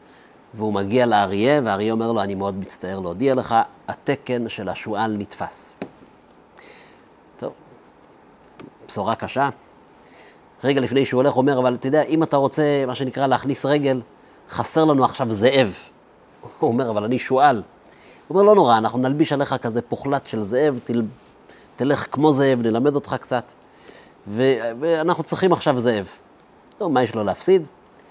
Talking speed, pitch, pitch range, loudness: 150 wpm, 125 Hz, 110-140 Hz, -20 LUFS